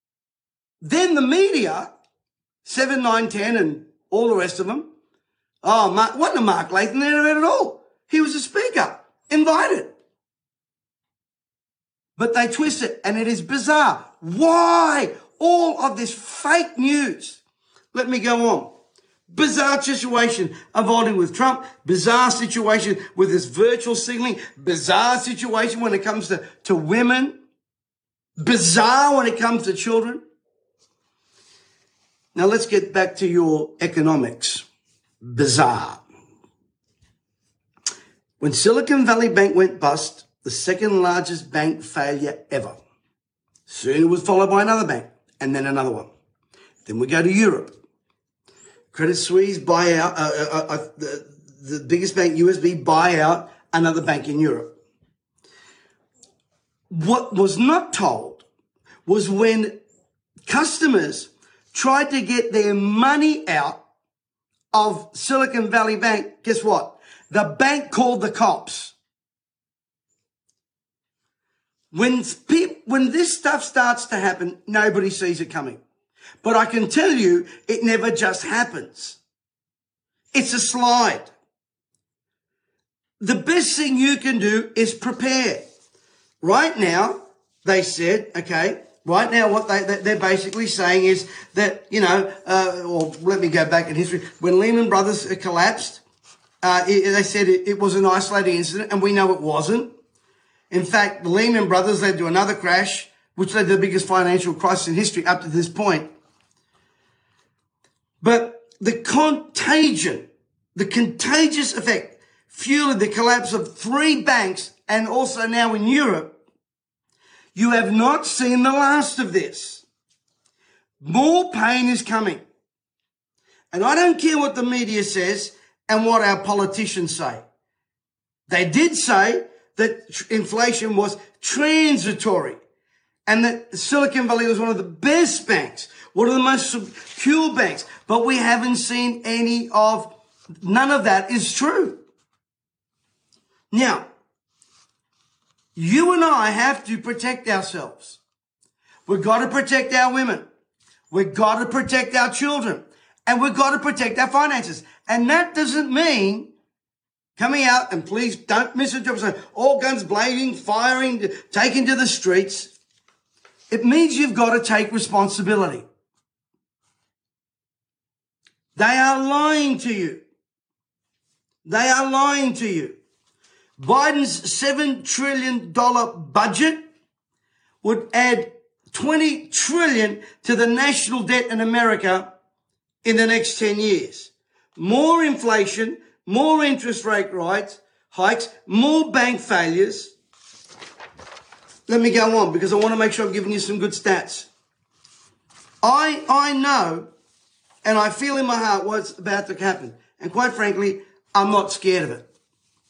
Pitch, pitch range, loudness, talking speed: 225 Hz, 190-260 Hz, -19 LUFS, 135 wpm